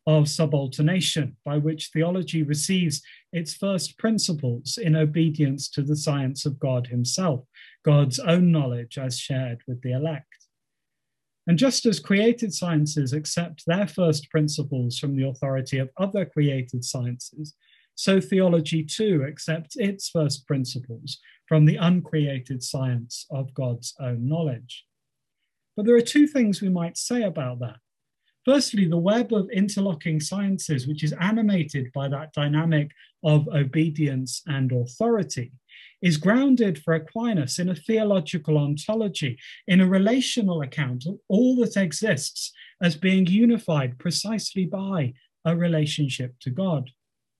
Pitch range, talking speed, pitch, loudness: 135-190 Hz, 135 wpm, 155 Hz, -24 LUFS